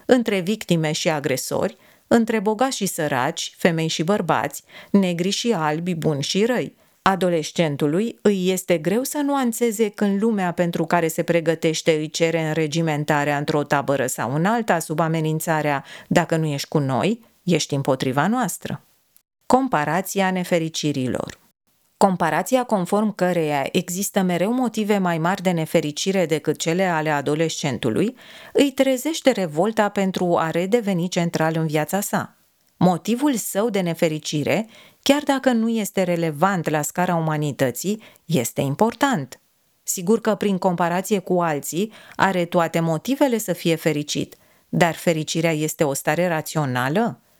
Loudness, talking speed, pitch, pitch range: -21 LUFS, 135 wpm, 175 Hz, 155-205 Hz